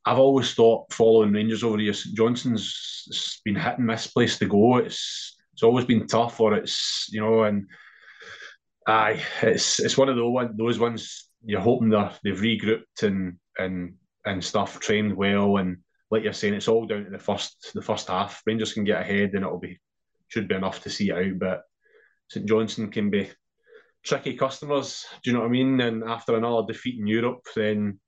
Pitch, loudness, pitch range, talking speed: 110 Hz, -24 LUFS, 105-120 Hz, 190 wpm